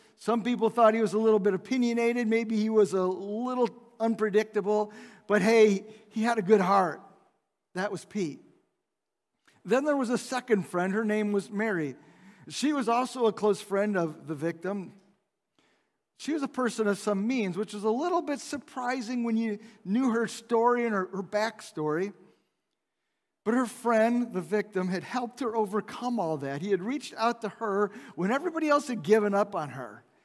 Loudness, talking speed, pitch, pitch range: -28 LUFS, 180 wpm, 220 Hz, 200-240 Hz